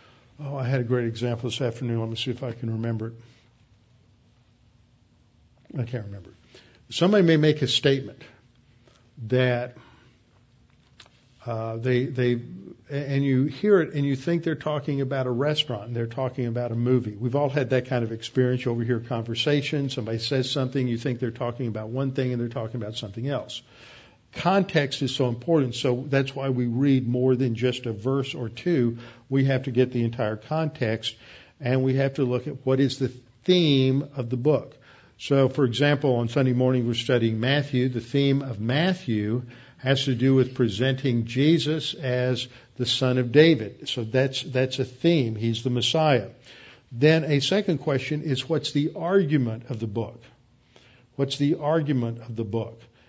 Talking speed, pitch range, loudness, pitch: 180 wpm, 120-140 Hz, -25 LUFS, 125 Hz